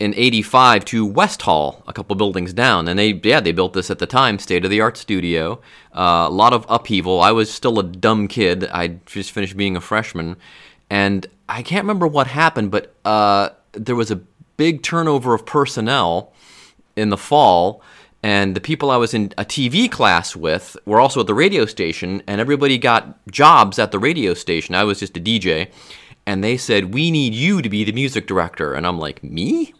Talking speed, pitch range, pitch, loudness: 205 wpm, 95-125 Hz, 105 Hz, -17 LUFS